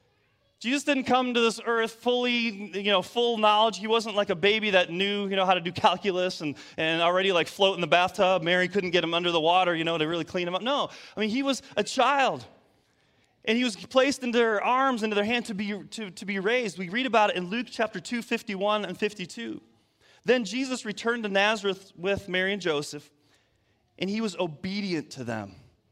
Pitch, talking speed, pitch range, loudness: 200 Hz, 220 wpm, 180-230 Hz, -26 LUFS